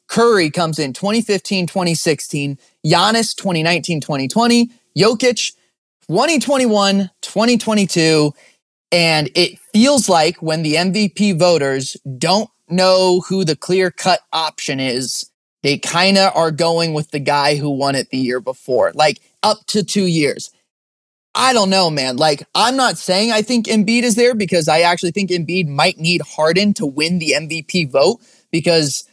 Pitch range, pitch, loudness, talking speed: 155-205 Hz, 175 Hz, -15 LUFS, 150 wpm